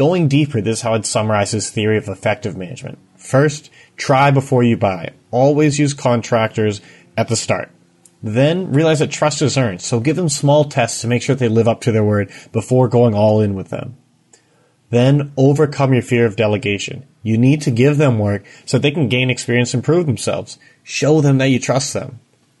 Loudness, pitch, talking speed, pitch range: -16 LUFS, 120 Hz, 200 wpm, 110-140 Hz